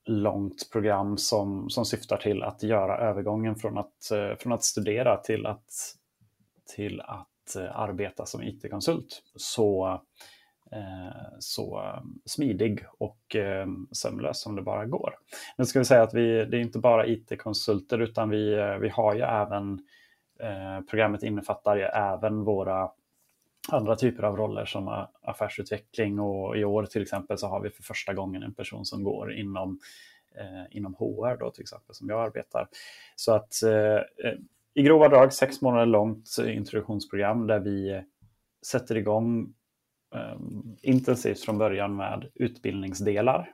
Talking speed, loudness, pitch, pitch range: 150 wpm, -27 LUFS, 105 Hz, 100-115 Hz